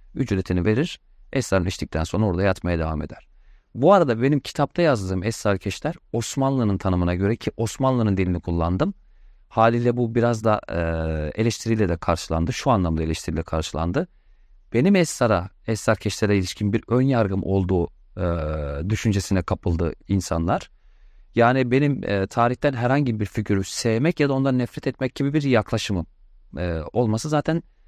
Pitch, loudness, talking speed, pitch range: 105 Hz, -23 LUFS, 135 wpm, 90-125 Hz